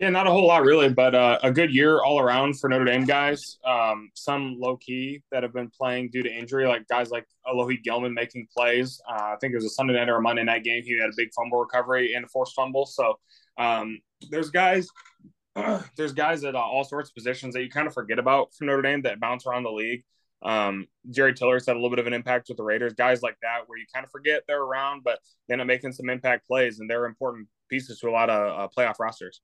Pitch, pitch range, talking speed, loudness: 125 Hz, 120-135 Hz, 255 wpm, -24 LUFS